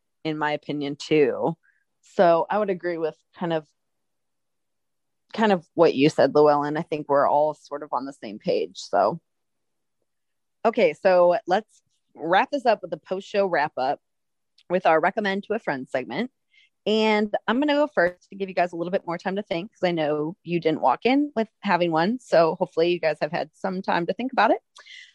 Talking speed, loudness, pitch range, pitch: 200 wpm, -23 LUFS, 155-205 Hz, 175 Hz